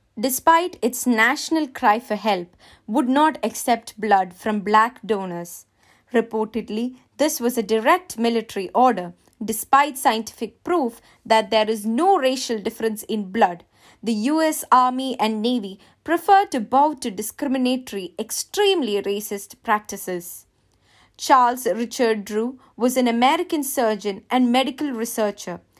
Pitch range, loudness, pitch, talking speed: 215-265 Hz, -21 LUFS, 230 Hz, 130 wpm